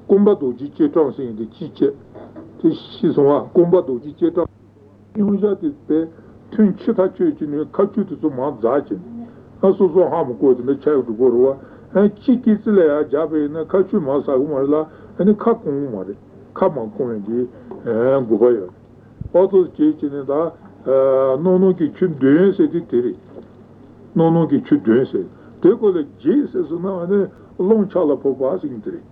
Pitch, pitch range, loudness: 175 Hz, 135-210 Hz, -18 LUFS